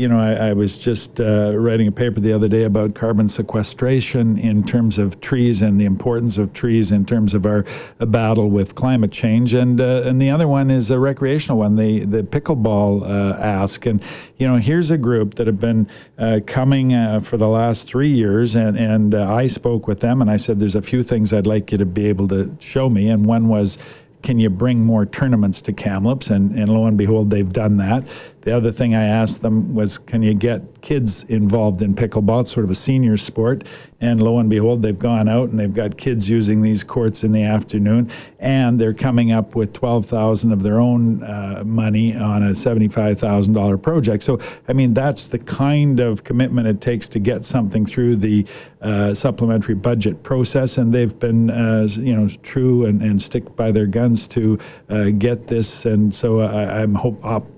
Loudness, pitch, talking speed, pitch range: -17 LUFS, 110 Hz, 210 wpm, 105-120 Hz